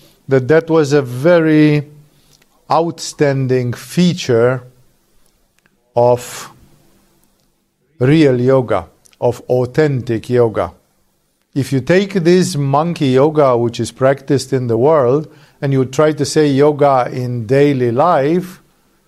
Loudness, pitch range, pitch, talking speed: -14 LUFS, 125-155 Hz, 135 Hz, 105 wpm